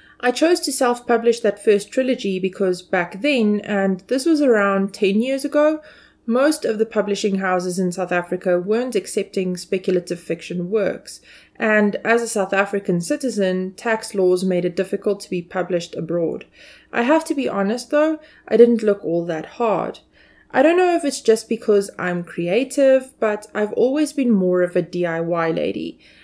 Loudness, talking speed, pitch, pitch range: -20 LUFS, 170 wpm, 205 Hz, 185-245 Hz